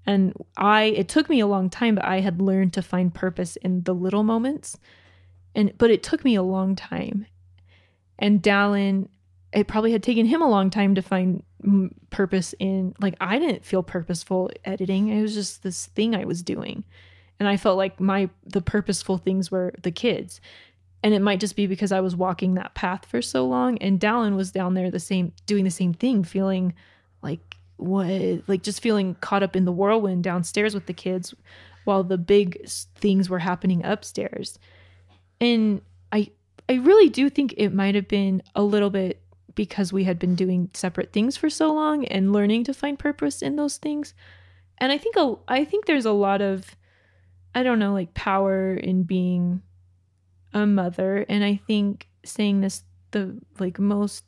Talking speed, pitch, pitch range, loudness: 190 wpm, 195 Hz, 180-210 Hz, -23 LUFS